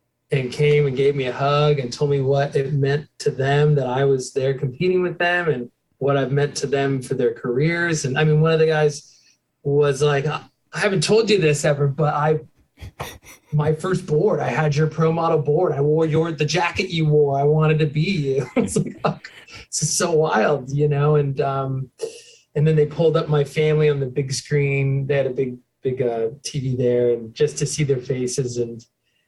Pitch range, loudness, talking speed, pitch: 135-155 Hz, -20 LUFS, 215 wpm, 145 Hz